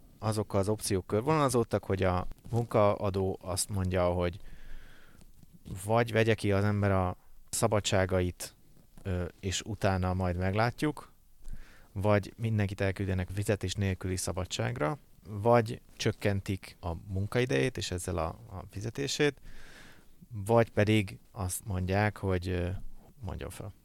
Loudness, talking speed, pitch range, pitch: -31 LUFS, 110 wpm, 95-110 Hz, 100 Hz